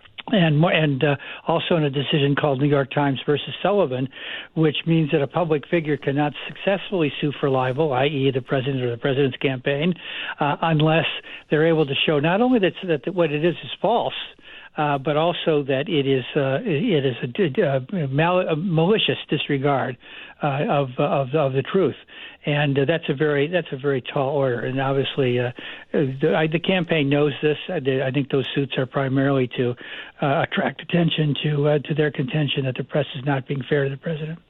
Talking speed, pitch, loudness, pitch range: 190 wpm, 145 Hz, -22 LUFS, 140-160 Hz